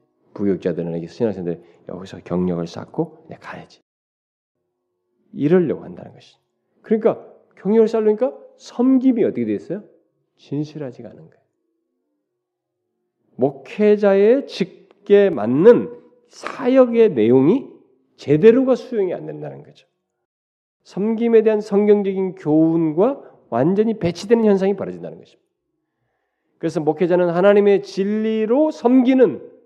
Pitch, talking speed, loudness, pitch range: 200 Hz, 285 characters per minute, -18 LUFS, 150-235 Hz